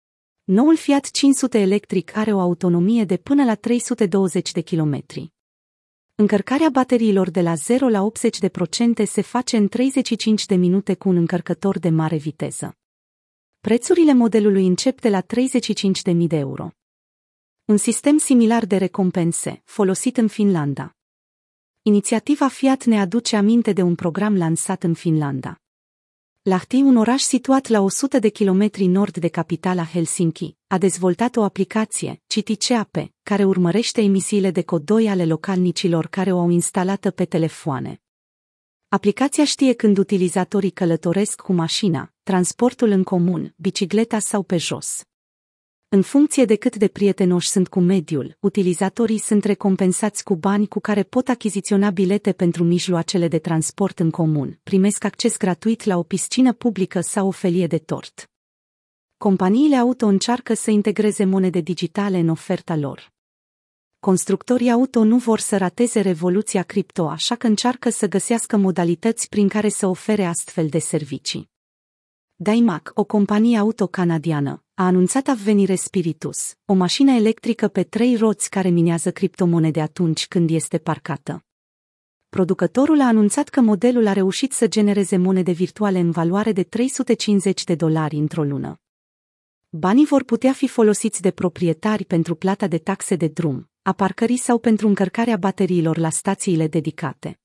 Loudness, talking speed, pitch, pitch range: -19 LUFS, 145 wpm, 195 Hz, 175-220 Hz